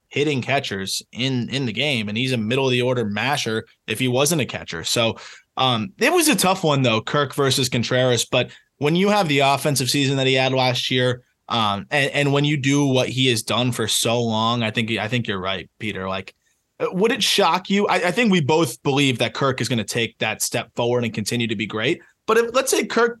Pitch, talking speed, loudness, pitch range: 125 Hz, 240 wpm, -20 LUFS, 115-145 Hz